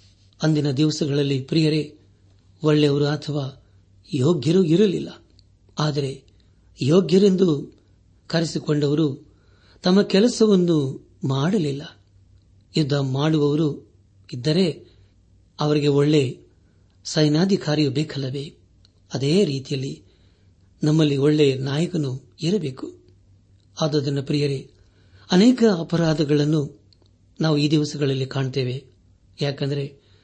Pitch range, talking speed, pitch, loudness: 100-155 Hz, 70 wpm, 140 Hz, -21 LUFS